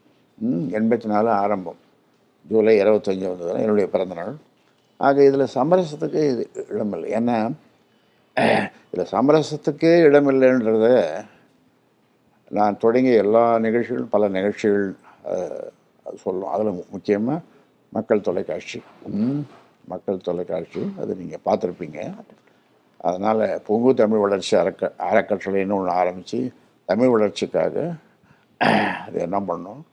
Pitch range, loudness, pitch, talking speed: 100-140 Hz, -21 LUFS, 110 Hz, 95 wpm